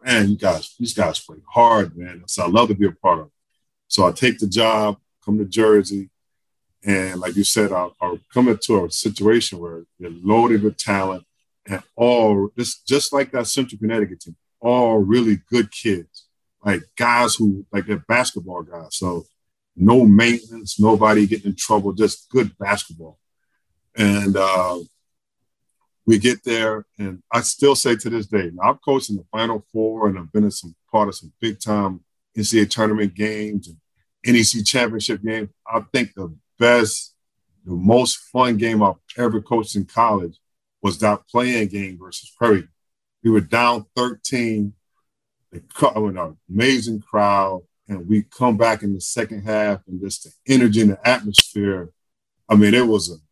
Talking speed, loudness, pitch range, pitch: 170 wpm, -19 LUFS, 100-115 Hz, 105 Hz